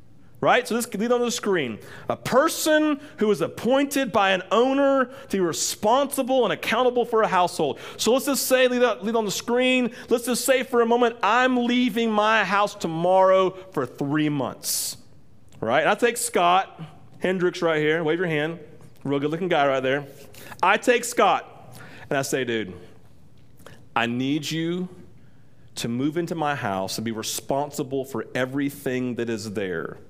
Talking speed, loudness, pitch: 170 wpm, -23 LUFS, 180 Hz